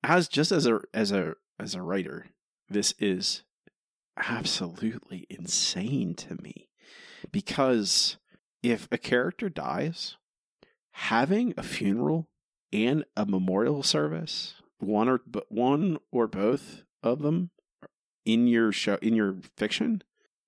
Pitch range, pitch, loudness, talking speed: 105-165 Hz, 120 Hz, -28 LUFS, 120 wpm